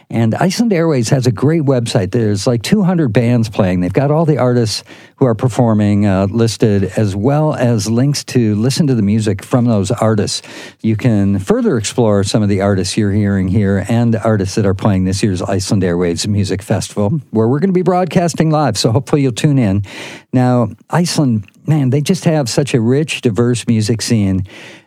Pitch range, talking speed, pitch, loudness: 105-140 Hz, 195 wpm, 120 Hz, -14 LUFS